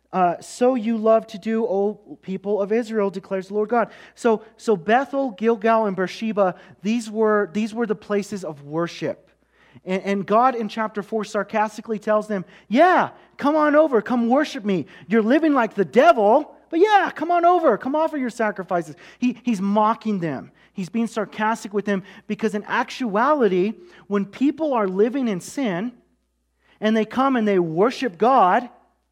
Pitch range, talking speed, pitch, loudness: 200-245 Hz, 170 wpm, 220 Hz, -21 LUFS